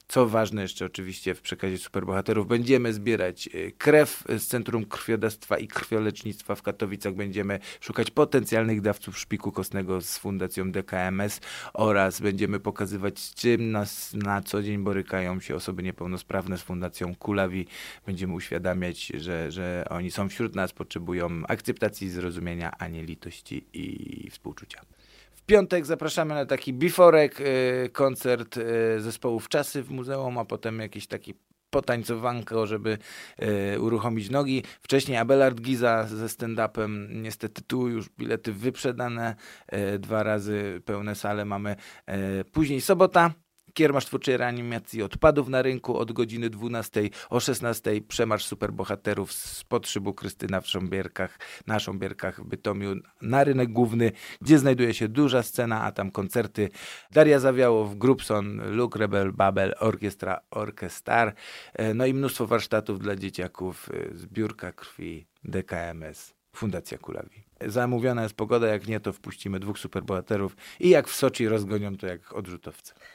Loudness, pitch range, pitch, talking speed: -27 LUFS, 95-120 Hz, 105 Hz, 135 wpm